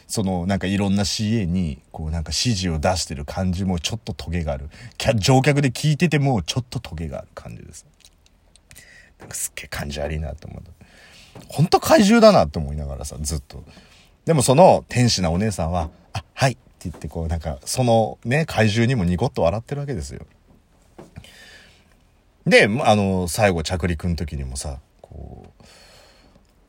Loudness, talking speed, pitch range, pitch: -20 LUFS, 335 characters per minute, 80-110 Hz, 90 Hz